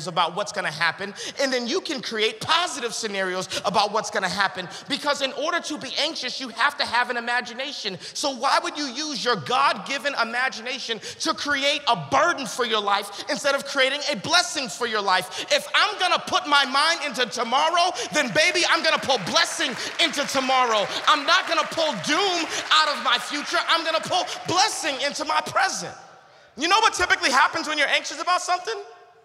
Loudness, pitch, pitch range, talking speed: -22 LUFS, 280 Hz, 235-320 Hz, 190 wpm